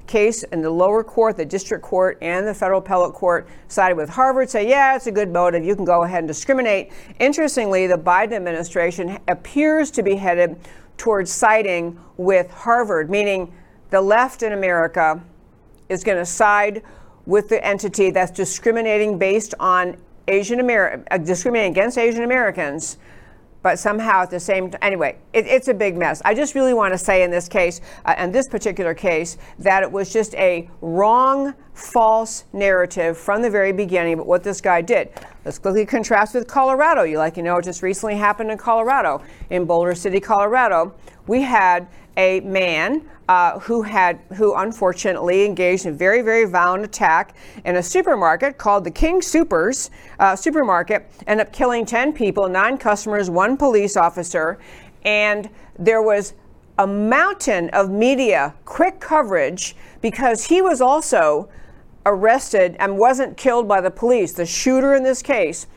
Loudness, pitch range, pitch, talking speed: -18 LUFS, 180-230 Hz, 200 Hz, 170 wpm